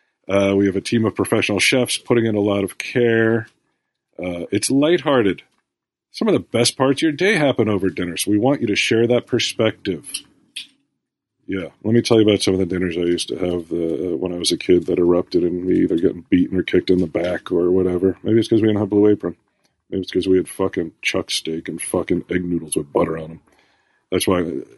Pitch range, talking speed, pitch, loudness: 90-115 Hz, 235 wpm, 100 Hz, -19 LUFS